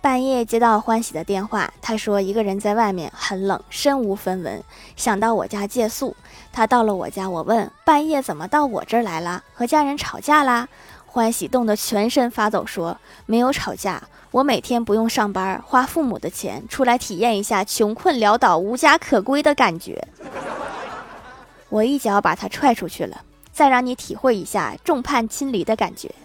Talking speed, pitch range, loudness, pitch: 270 characters per minute, 210-260 Hz, -20 LUFS, 230 Hz